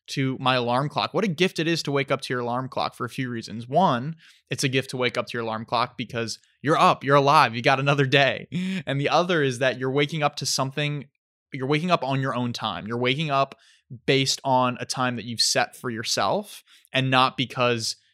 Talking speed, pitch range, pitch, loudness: 240 wpm, 125-145 Hz, 135 Hz, -23 LUFS